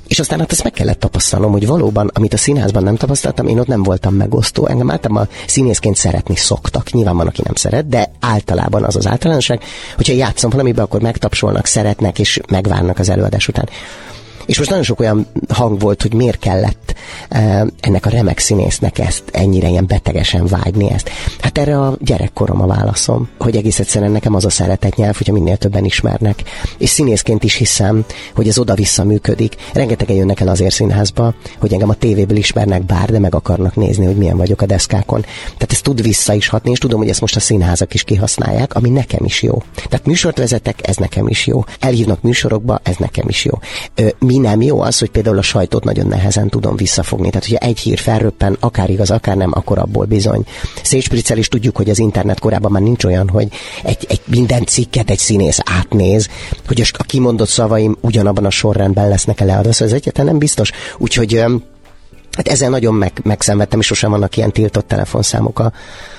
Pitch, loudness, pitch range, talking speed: 105 Hz, -13 LUFS, 100-120 Hz, 190 wpm